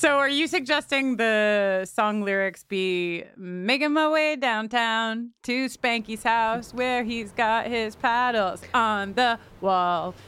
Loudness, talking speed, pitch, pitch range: -24 LUFS, 135 wpm, 230 Hz, 200-250 Hz